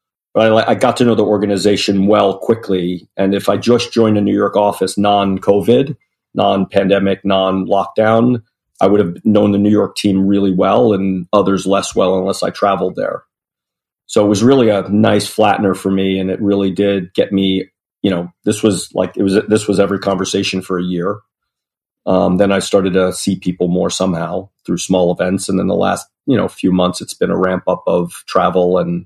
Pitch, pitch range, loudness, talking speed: 100 Hz, 95-105 Hz, -14 LUFS, 195 wpm